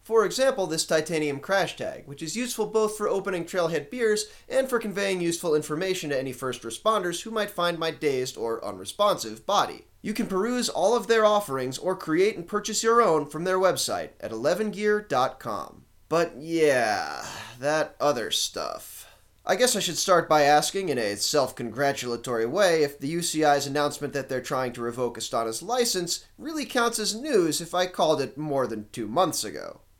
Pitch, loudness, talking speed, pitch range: 170 Hz, -26 LUFS, 180 wpm, 140-210 Hz